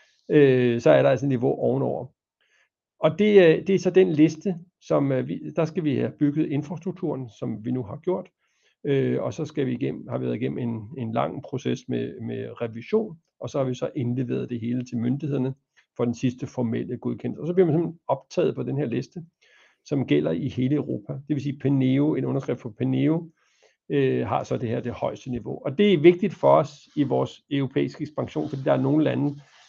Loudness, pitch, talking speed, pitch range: -24 LUFS, 140 Hz, 210 wpm, 125-160 Hz